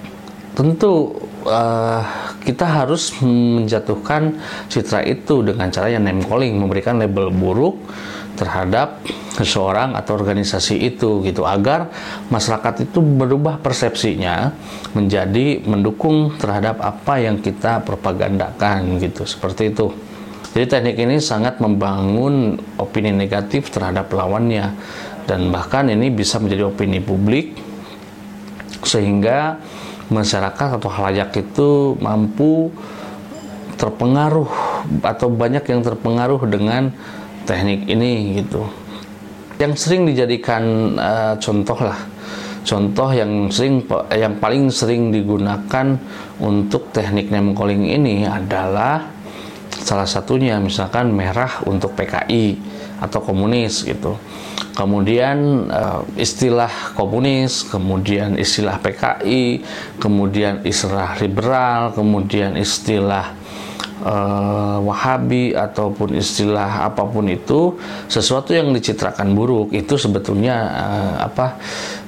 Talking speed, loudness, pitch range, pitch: 100 wpm, -18 LUFS, 100-120 Hz, 105 Hz